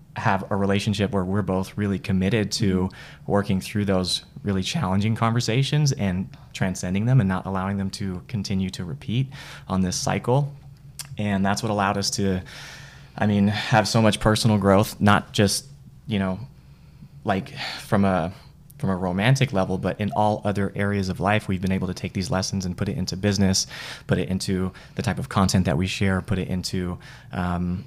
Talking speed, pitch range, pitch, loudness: 185 wpm, 95-115 Hz, 100 Hz, -24 LUFS